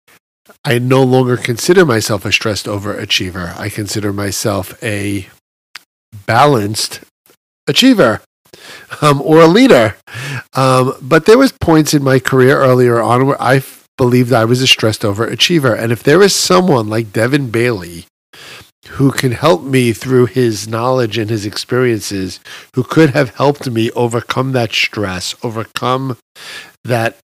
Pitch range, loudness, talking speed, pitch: 110-135 Hz, -12 LUFS, 145 wpm, 125 Hz